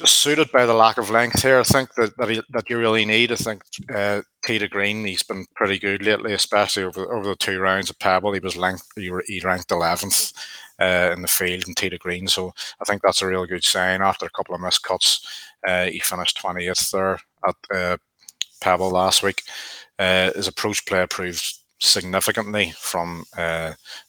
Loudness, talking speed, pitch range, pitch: -20 LUFS, 195 wpm, 90-110 Hz, 95 Hz